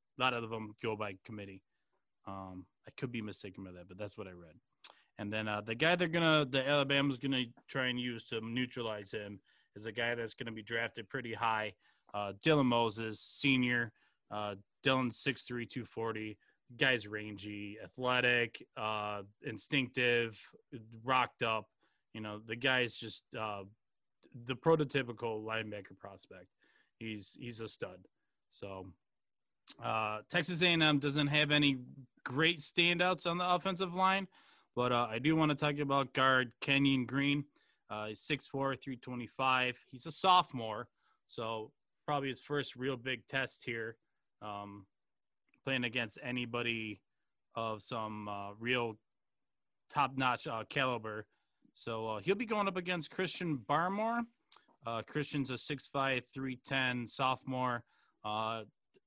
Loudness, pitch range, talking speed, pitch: -35 LUFS, 110-140 Hz, 145 wpm, 120 Hz